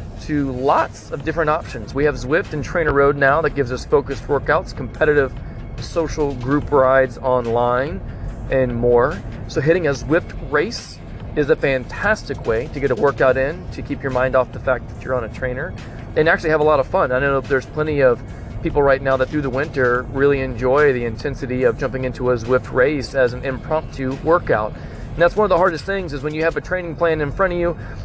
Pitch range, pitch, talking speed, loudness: 125-150 Hz, 135 Hz, 220 wpm, -19 LUFS